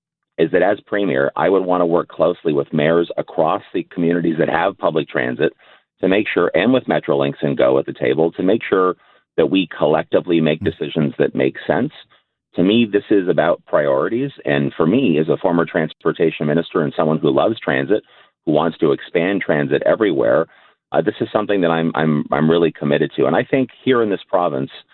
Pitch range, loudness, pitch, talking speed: 75-90 Hz, -18 LUFS, 80 Hz, 205 wpm